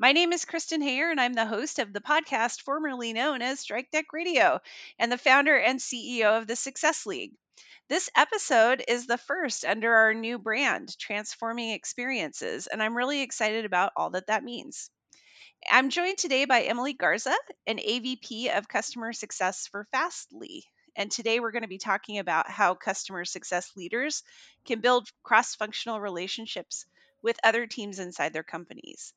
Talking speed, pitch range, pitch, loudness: 170 wpm, 215-285 Hz, 240 Hz, -27 LUFS